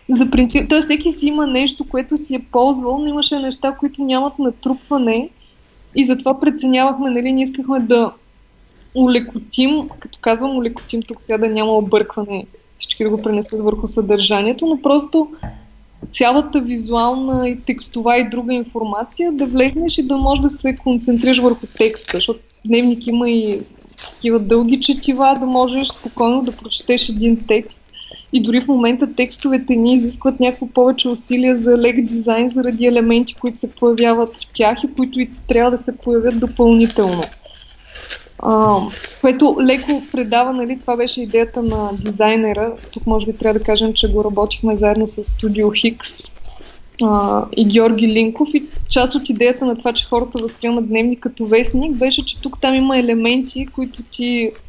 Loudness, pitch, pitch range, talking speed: -16 LUFS, 245 Hz, 230-265 Hz, 160 wpm